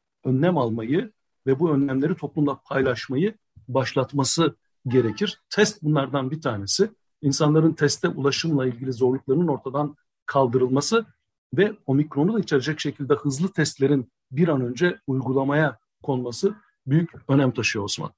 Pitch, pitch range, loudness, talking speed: 145 Hz, 135-165 Hz, -23 LUFS, 120 wpm